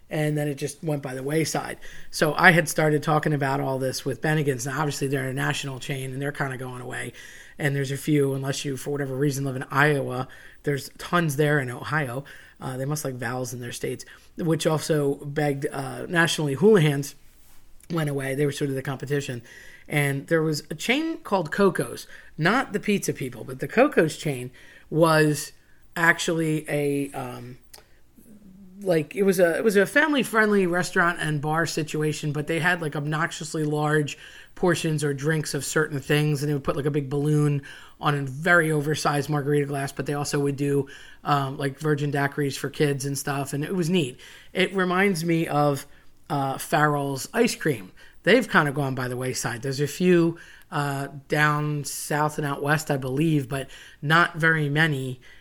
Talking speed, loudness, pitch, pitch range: 190 wpm, -24 LUFS, 150 Hz, 140-160 Hz